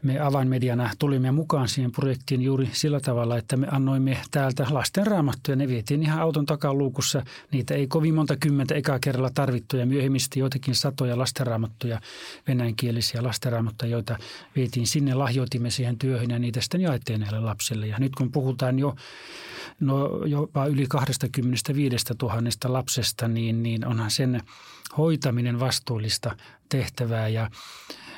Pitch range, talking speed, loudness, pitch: 120-140 Hz, 135 wpm, -25 LUFS, 130 Hz